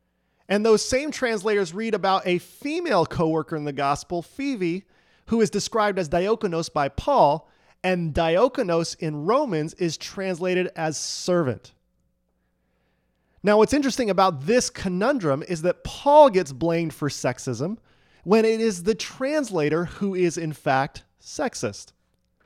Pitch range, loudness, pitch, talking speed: 145-210 Hz, -23 LUFS, 175 Hz, 135 wpm